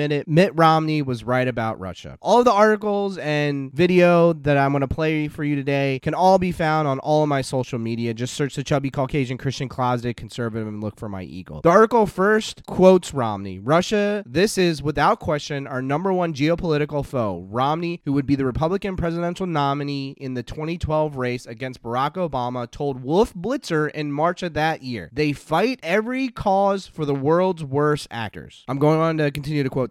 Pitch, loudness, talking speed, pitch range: 150 Hz, -21 LUFS, 195 wpm, 130-170 Hz